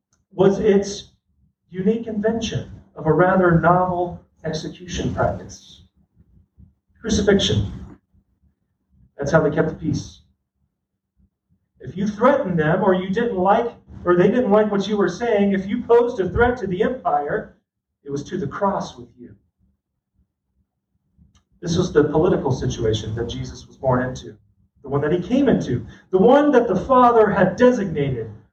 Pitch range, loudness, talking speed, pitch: 125-210 Hz, -19 LUFS, 150 wpm, 180 Hz